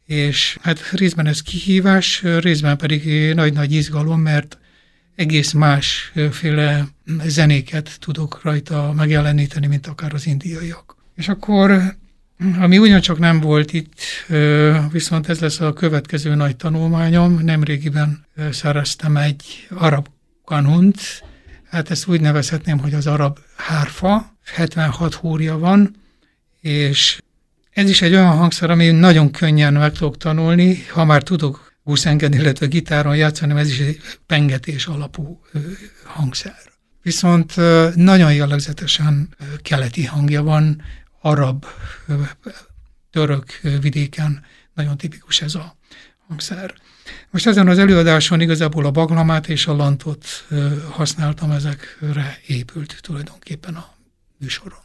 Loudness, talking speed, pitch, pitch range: -16 LUFS, 115 wpm, 155 Hz, 145-170 Hz